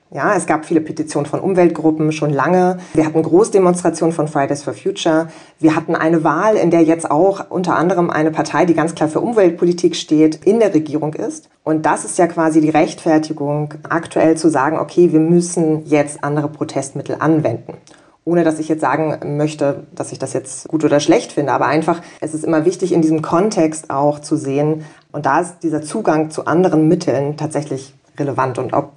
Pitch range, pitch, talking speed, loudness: 150-170 Hz, 155 Hz, 195 wpm, -16 LUFS